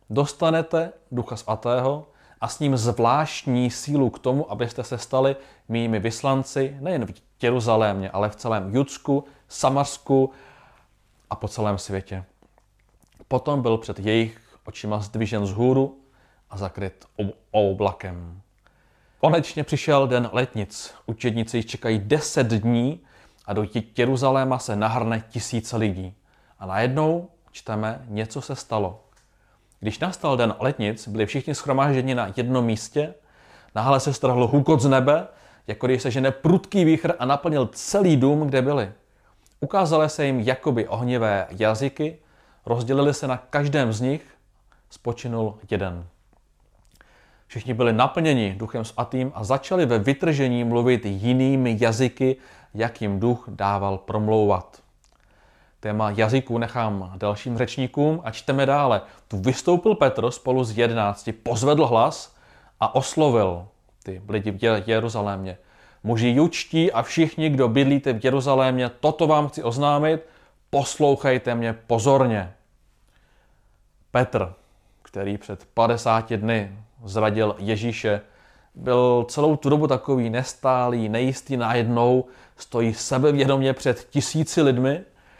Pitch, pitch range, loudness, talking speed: 120 Hz, 110-135 Hz, -23 LUFS, 125 wpm